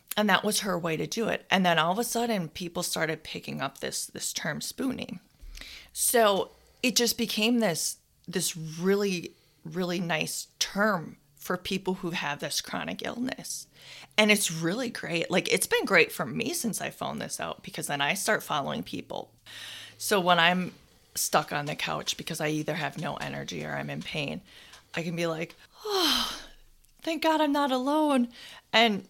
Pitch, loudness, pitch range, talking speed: 185 Hz, -28 LUFS, 165-230 Hz, 180 wpm